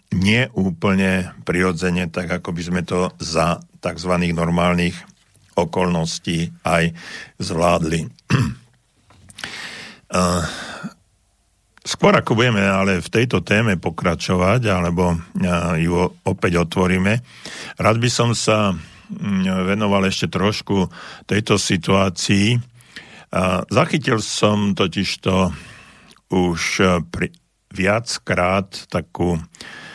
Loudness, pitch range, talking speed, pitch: -19 LUFS, 85-100 Hz, 85 wpm, 90 Hz